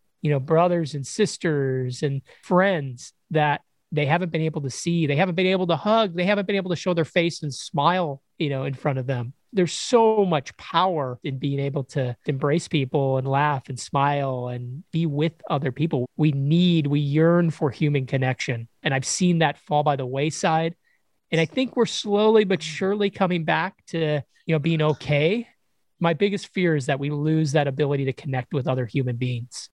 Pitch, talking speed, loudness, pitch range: 155 Hz, 200 wpm, -23 LUFS, 140-175 Hz